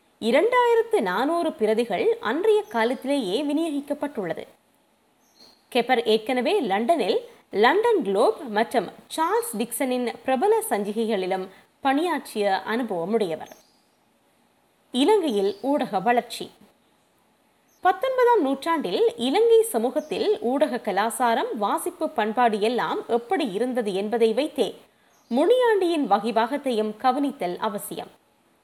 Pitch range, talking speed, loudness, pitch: 225-345 Hz, 80 wpm, -23 LUFS, 260 Hz